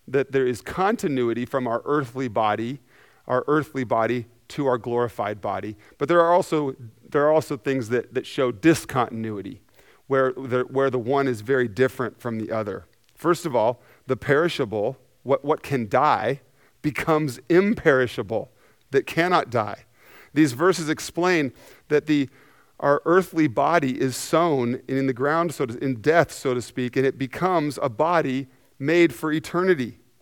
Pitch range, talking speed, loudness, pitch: 125-150 Hz, 160 wpm, -23 LUFS, 135 Hz